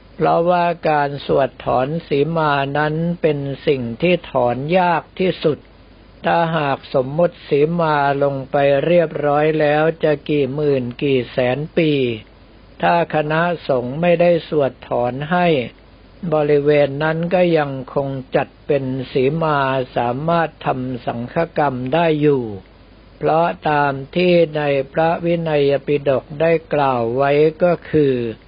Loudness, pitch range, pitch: -18 LUFS, 135-165 Hz, 145 Hz